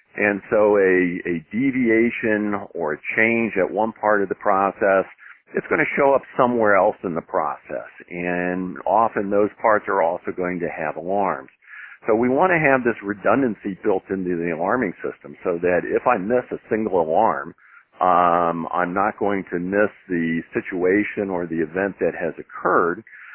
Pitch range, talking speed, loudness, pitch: 90-110 Hz, 175 wpm, -21 LUFS, 100 Hz